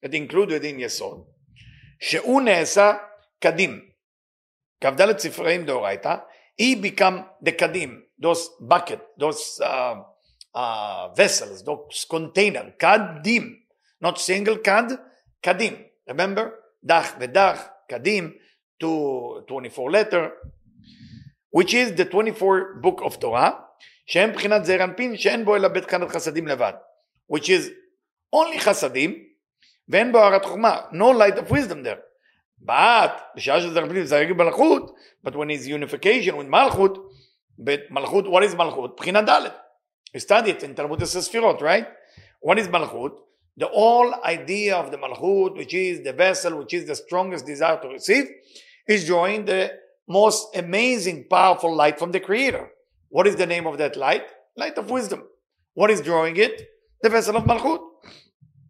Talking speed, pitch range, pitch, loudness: 130 wpm, 165-225 Hz, 190 Hz, -21 LUFS